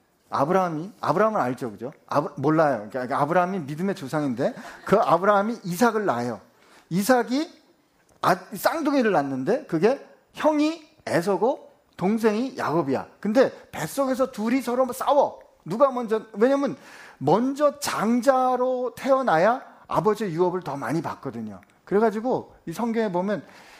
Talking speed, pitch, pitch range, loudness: 310 characters per minute, 215 Hz, 155-255 Hz, -24 LUFS